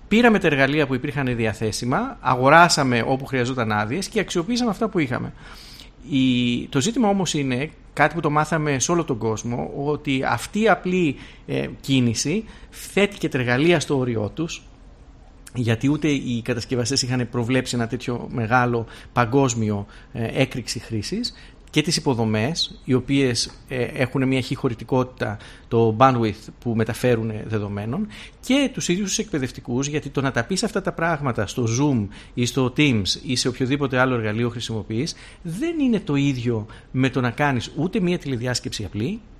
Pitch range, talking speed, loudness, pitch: 120-155 Hz, 155 wpm, -22 LUFS, 130 Hz